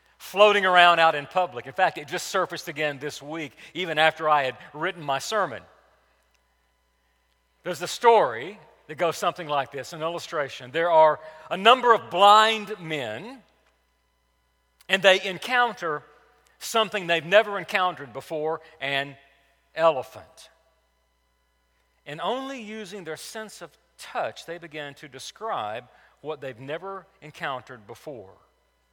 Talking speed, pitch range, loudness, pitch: 130 wpm, 135-185 Hz, -23 LUFS, 155 Hz